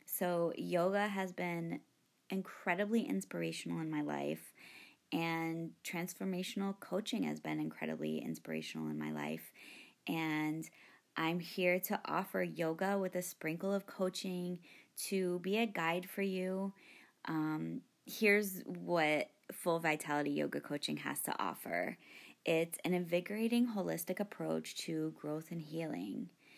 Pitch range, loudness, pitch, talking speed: 145-190 Hz, -38 LUFS, 170 Hz, 125 wpm